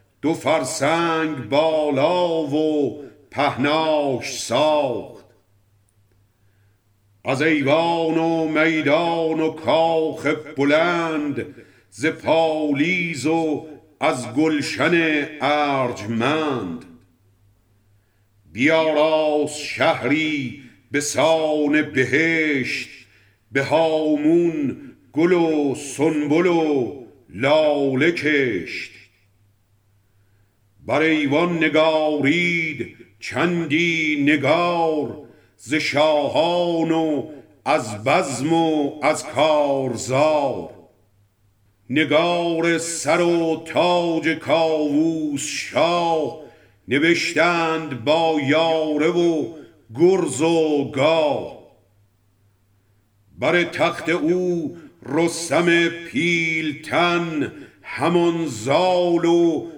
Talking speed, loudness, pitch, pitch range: 65 wpm, -20 LUFS, 155 Hz, 125-165 Hz